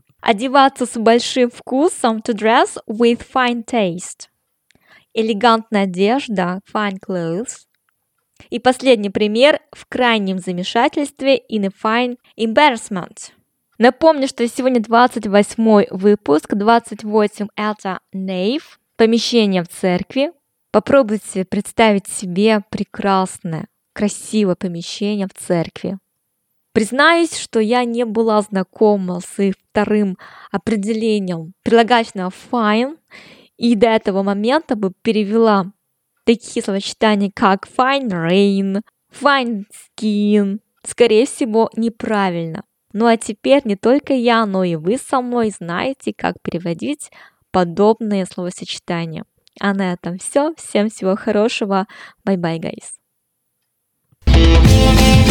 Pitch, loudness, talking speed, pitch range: 215 Hz, -17 LUFS, 105 wpm, 195-235 Hz